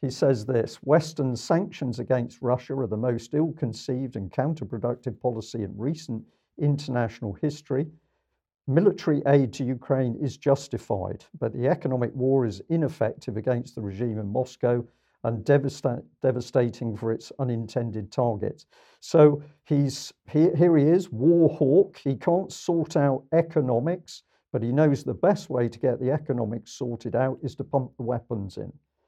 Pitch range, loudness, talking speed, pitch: 120-150 Hz, -26 LUFS, 155 wpm, 130 Hz